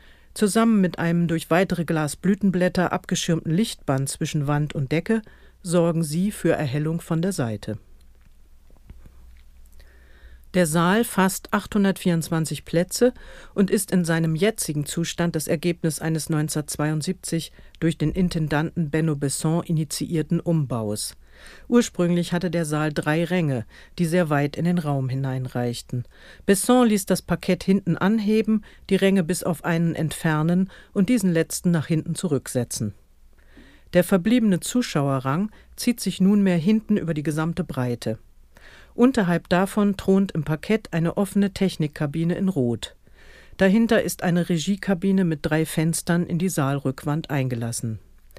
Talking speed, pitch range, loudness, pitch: 130 wpm, 145-185 Hz, -23 LUFS, 165 Hz